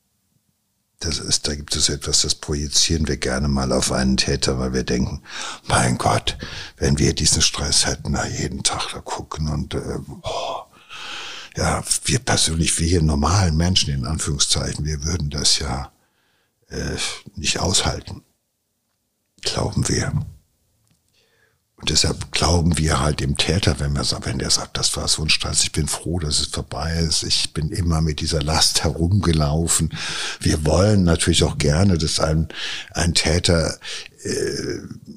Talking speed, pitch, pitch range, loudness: 155 wpm, 80 Hz, 70-85 Hz, -20 LUFS